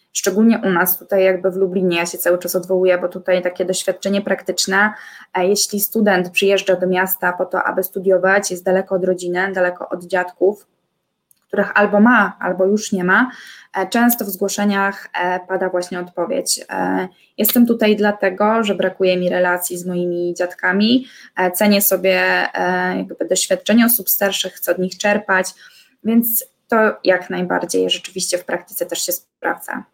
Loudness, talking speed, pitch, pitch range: -17 LUFS, 150 wpm, 190 Hz, 180-205 Hz